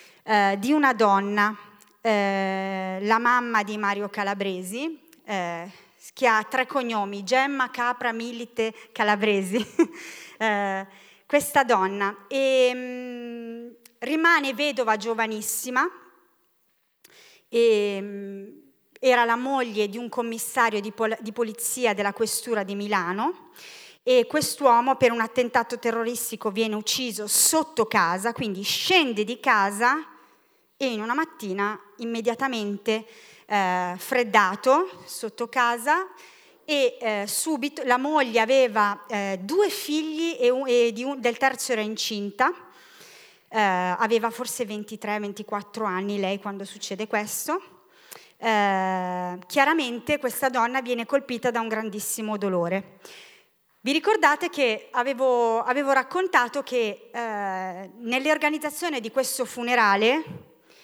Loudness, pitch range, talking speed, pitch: -24 LUFS, 210-270 Hz, 115 wpm, 235 Hz